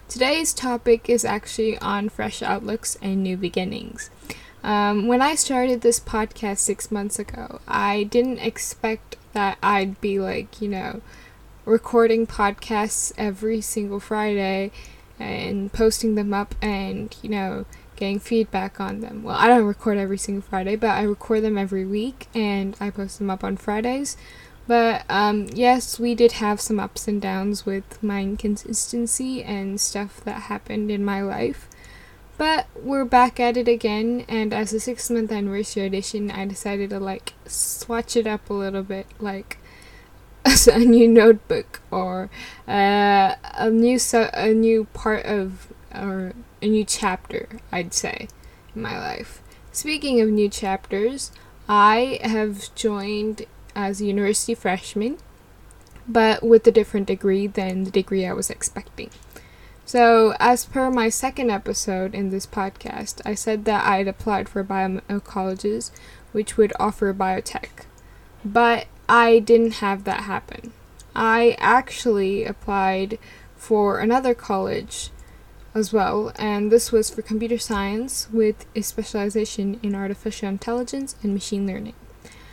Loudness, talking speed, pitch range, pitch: -22 LUFS, 145 wpm, 200-230 Hz, 215 Hz